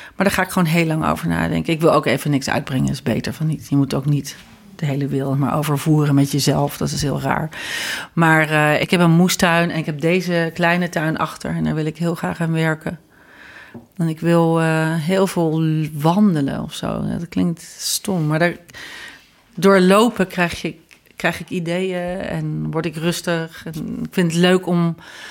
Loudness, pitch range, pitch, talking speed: -19 LUFS, 150-180 Hz, 165 Hz, 205 wpm